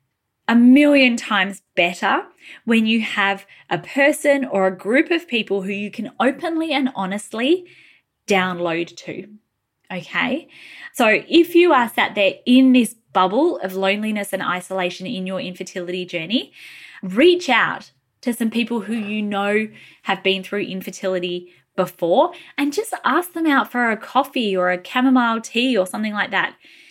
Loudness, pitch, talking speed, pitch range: -19 LUFS, 220 Hz, 155 wpm, 190-265 Hz